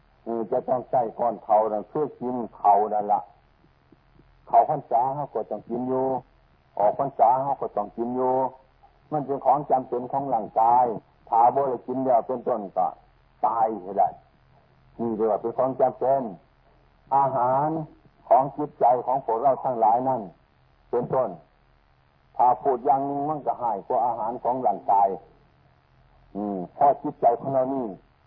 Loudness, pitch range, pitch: -24 LUFS, 105-135 Hz, 120 Hz